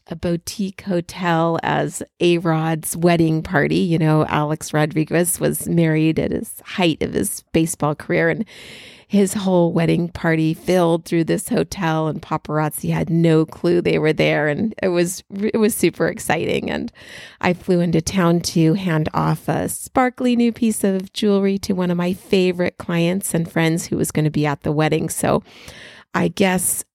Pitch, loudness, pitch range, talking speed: 170 Hz, -19 LUFS, 160-185 Hz, 175 wpm